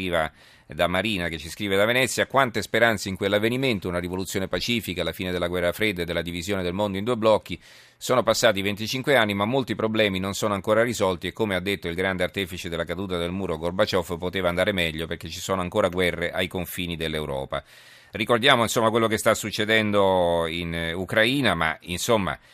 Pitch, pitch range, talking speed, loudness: 95 Hz, 85-110 Hz, 190 wpm, -24 LUFS